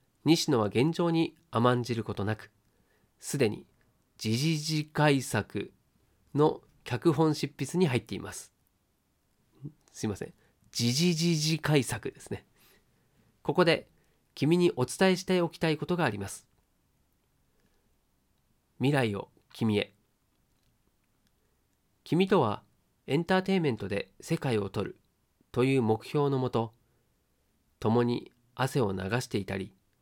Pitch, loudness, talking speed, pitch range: 120 Hz, -29 LUFS, 220 characters per minute, 105-155 Hz